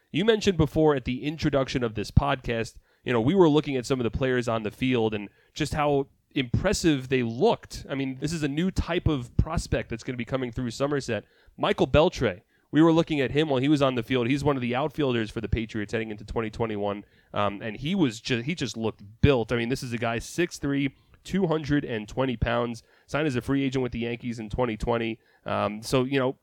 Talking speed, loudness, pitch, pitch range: 225 wpm, -26 LUFS, 125 Hz, 115-145 Hz